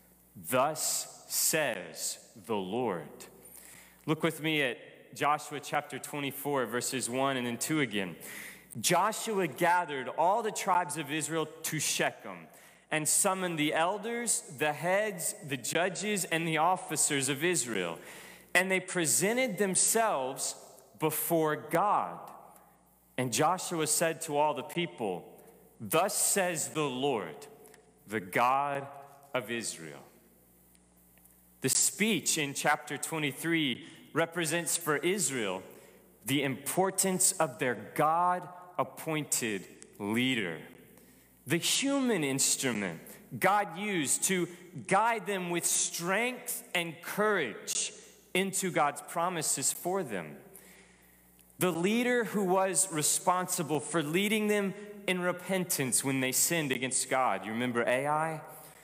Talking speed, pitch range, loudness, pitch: 110 wpm, 140-185 Hz, -30 LUFS, 160 Hz